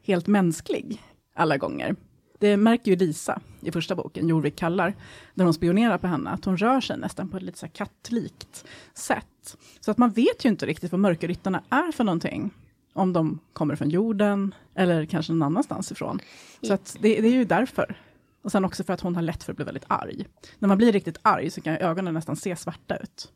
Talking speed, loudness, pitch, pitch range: 215 wpm, -25 LUFS, 190 Hz, 165-210 Hz